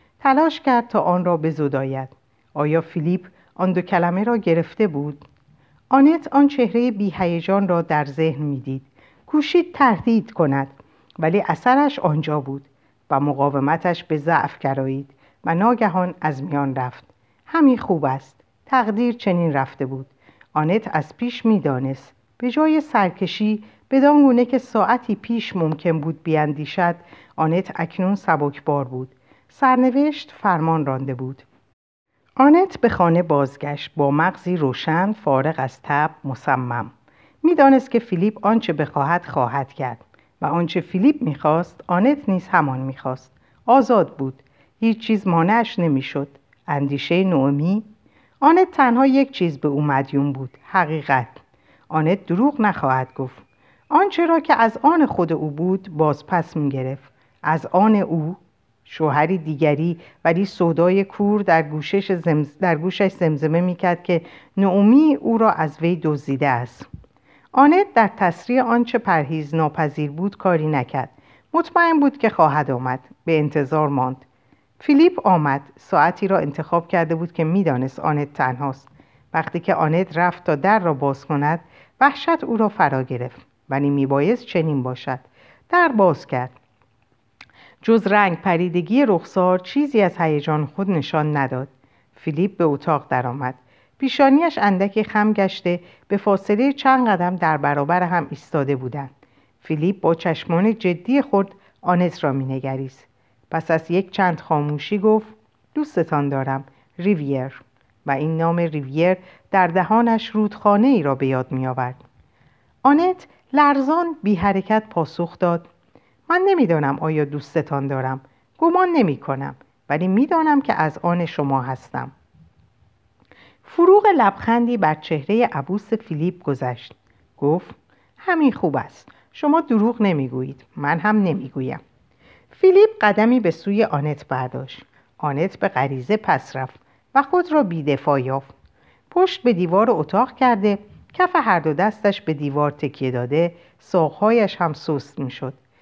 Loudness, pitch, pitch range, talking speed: -19 LUFS, 170 Hz, 140-215 Hz, 135 wpm